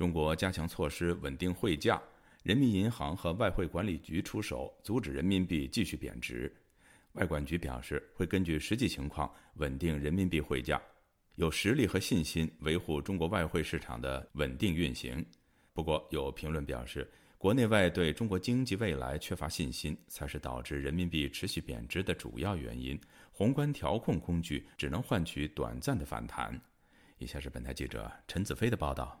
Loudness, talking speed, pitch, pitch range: -35 LUFS, 275 characters per minute, 80 Hz, 70-95 Hz